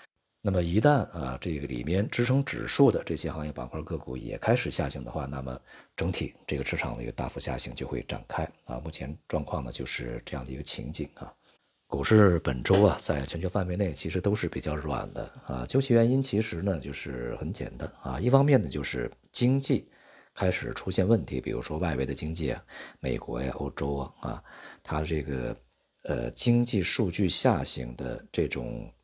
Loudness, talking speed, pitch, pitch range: -28 LUFS, 290 characters per minute, 80 Hz, 70-100 Hz